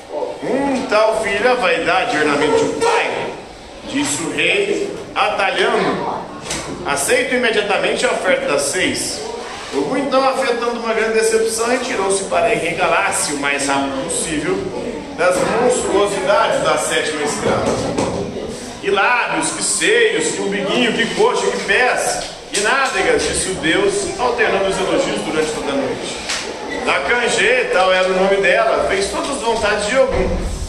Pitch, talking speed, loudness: 245 Hz, 135 wpm, -17 LUFS